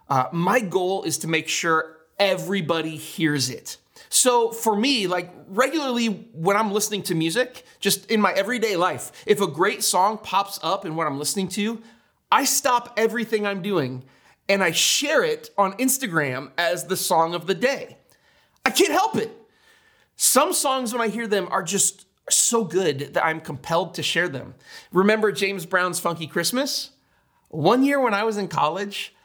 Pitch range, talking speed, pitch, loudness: 170-235 Hz, 175 wpm, 195 Hz, -22 LUFS